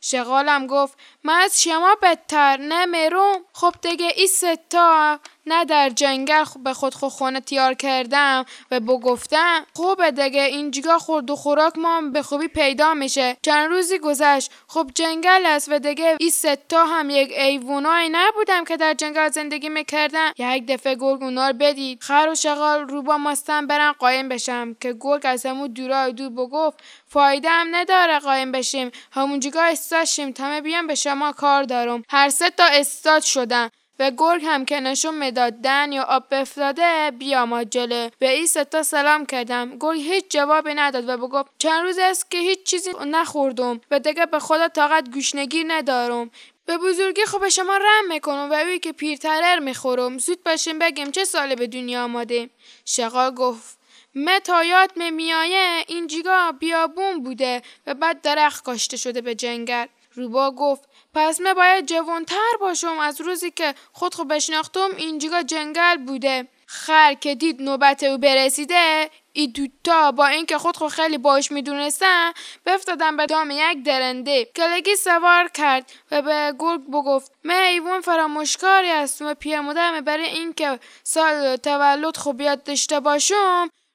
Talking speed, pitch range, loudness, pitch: 160 wpm, 270-330 Hz, -19 LUFS, 300 Hz